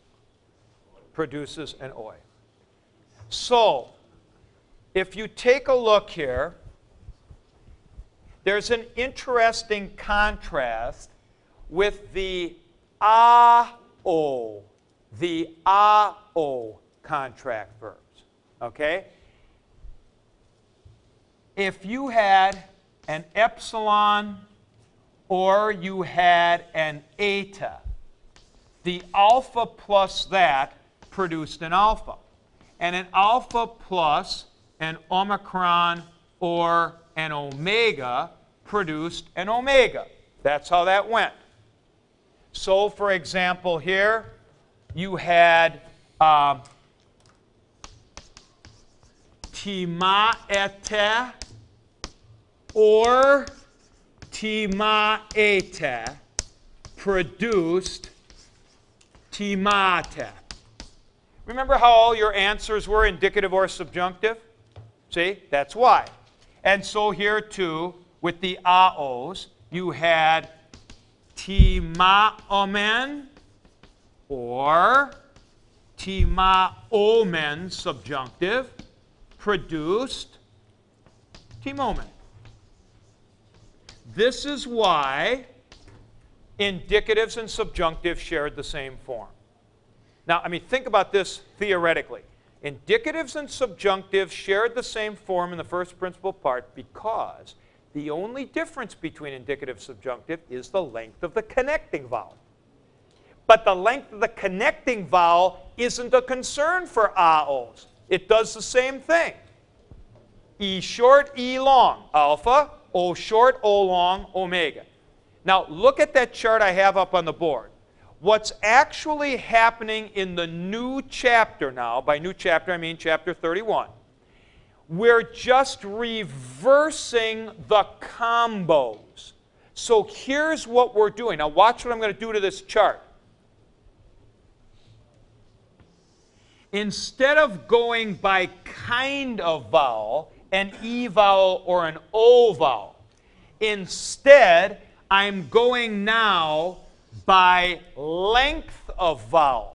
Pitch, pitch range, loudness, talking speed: 190 Hz, 150-220 Hz, -22 LUFS, 95 wpm